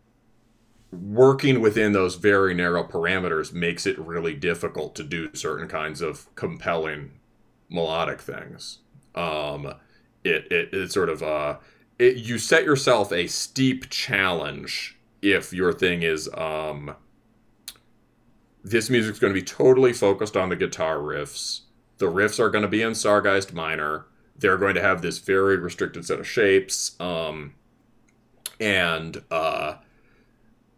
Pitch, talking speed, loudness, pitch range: 100 Hz, 135 wpm, -23 LUFS, 80-120 Hz